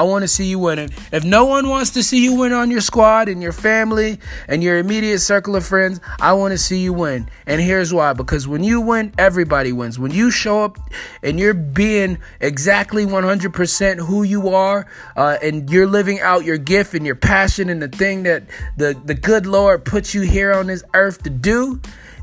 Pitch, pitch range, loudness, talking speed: 195 Hz, 170-210 Hz, -16 LUFS, 215 wpm